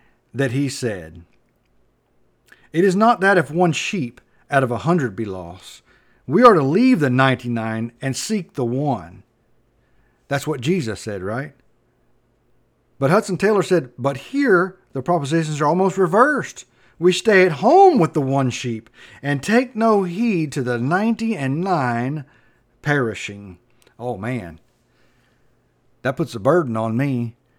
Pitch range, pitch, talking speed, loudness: 120-180 Hz, 135 Hz, 150 wpm, -19 LUFS